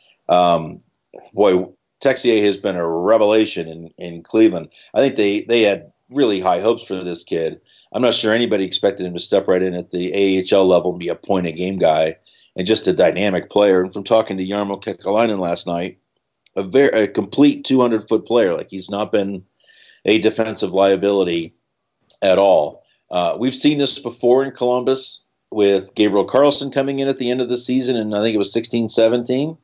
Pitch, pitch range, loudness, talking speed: 105 Hz, 90-125 Hz, -18 LUFS, 195 wpm